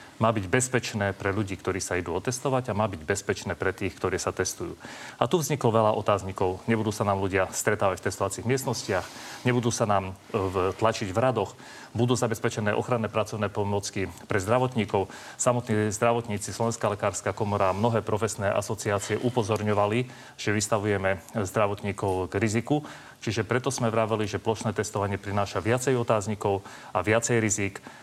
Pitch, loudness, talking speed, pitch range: 110 Hz, -27 LUFS, 155 wpm, 100-120 Hz